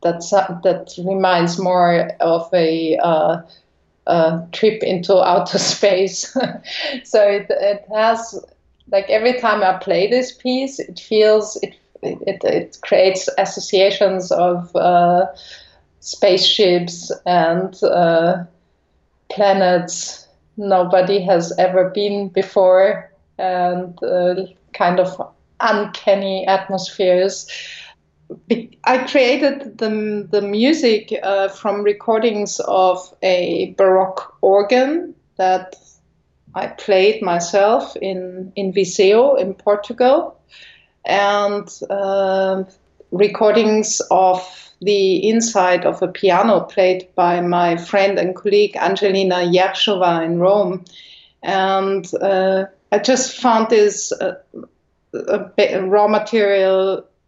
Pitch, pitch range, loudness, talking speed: 190 Hz, 180-210 Hz, -16 LUFS, 100 wpm